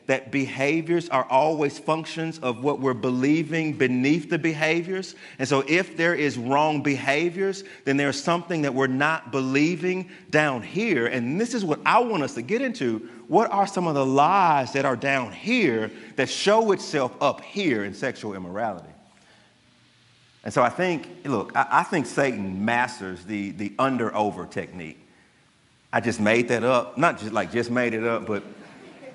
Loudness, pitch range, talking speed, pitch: -24 LUFS, 120-165 Hz, 170 wpm, 135 Hz